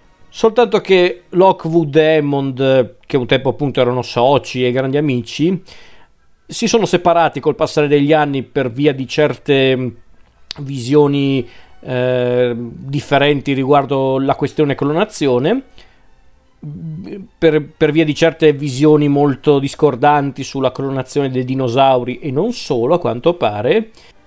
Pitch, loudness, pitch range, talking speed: 145 Hz, -15 LUFS, 130-155 Hz, 125 wpm